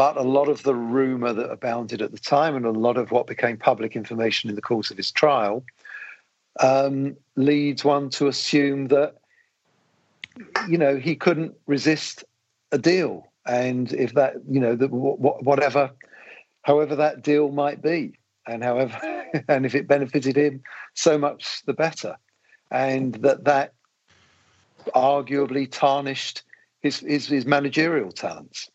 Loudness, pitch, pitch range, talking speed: -22 LUFS, 140 Hz, 130-145 Hz, 150 wpm